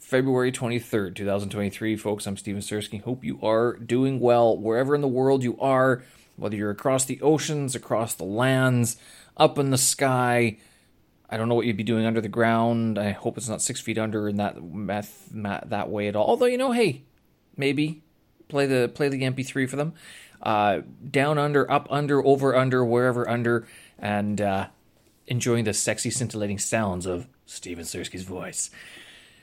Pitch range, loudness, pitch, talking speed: 105-130 Hz, -25 LUFS, 115 Hz, 180 wpm